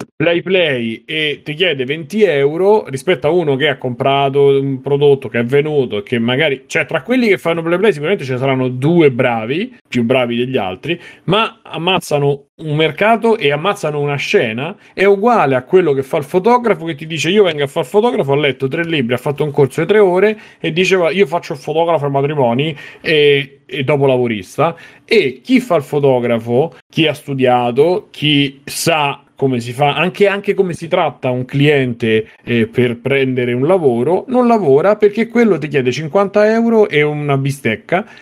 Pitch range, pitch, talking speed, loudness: 135-185 Hz, 150 Hz, 190 wpm, -14 LUFS